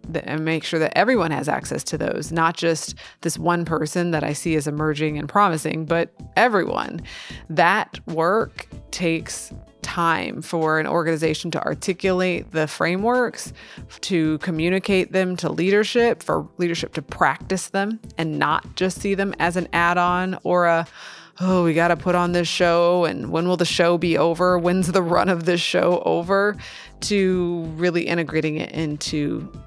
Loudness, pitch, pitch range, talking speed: -21 LUFS, 170 Hz, 160-180 Hz, 165 wpm